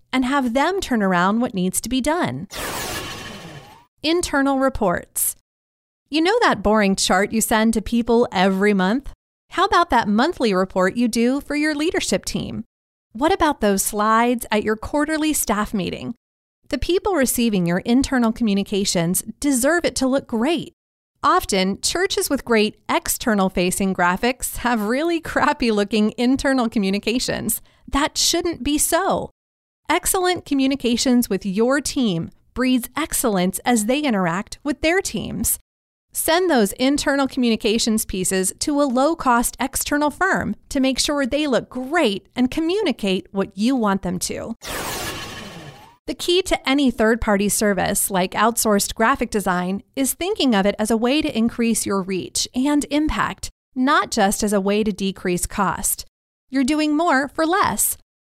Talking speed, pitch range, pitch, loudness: 150 wpm, 210-290 Hz, 245 Hz, -20 LUFS